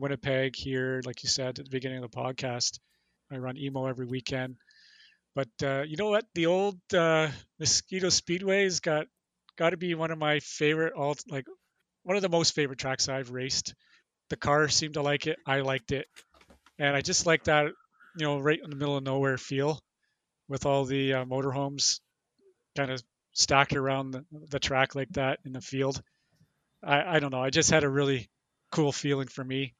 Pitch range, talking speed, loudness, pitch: 135-155 Hz, 195 wpm, -29 LUFS, 140 Hz